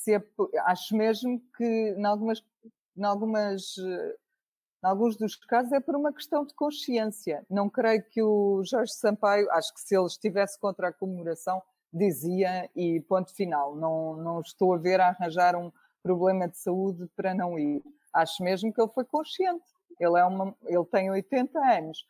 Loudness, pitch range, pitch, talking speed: -28 LUFS, 180-230 Hz, 200 Hz, 170 wpm